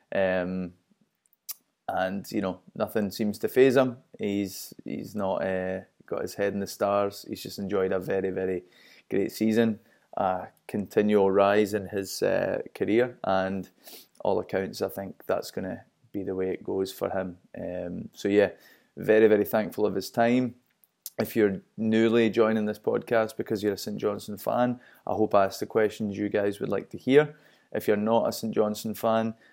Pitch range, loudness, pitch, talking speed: 95-115 Hz, -27 LUFS, 105 Hz, 180 wpm